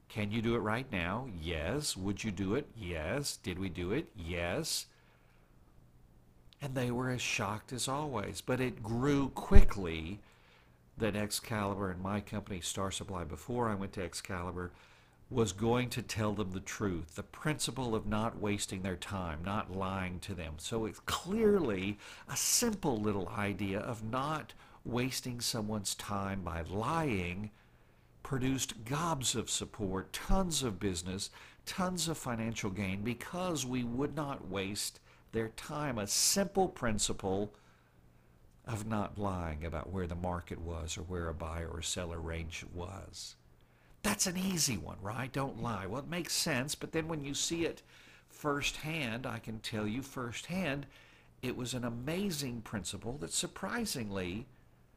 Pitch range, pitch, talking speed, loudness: 95-130 Hz, 105 Hz, 150 wpm, -36 LUFS